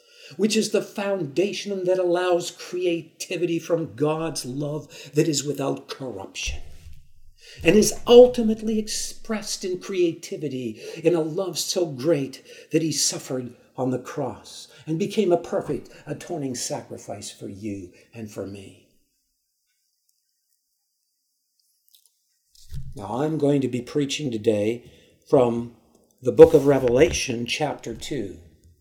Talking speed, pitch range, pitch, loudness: 115 wpm, 120-185 Hz, 155 Hz, -23 LUFS